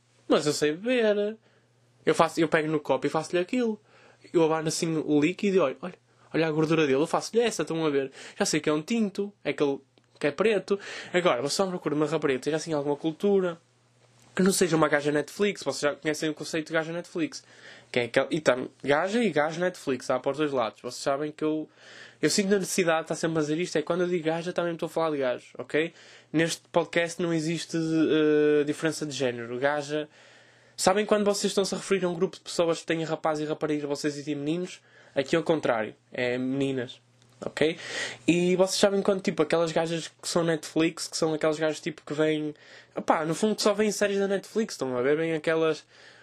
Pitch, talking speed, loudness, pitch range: 160 Hz, 225 wpm, -27 LUFS, 150-180 Hz